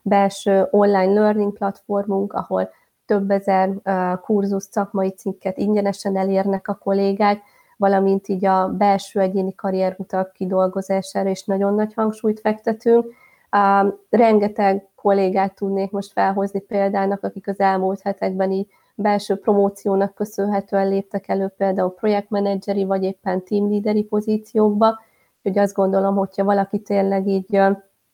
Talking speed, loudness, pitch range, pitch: 120 wpm, -20 LUFS, 195-205 Hz, 195 Hz